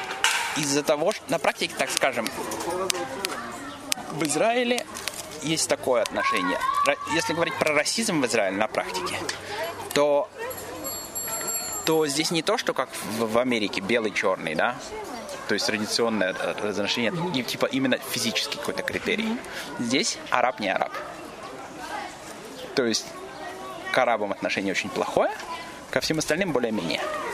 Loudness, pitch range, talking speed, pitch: -25 LUFS, 145-235 Hz, 120 wpm, 155 Hz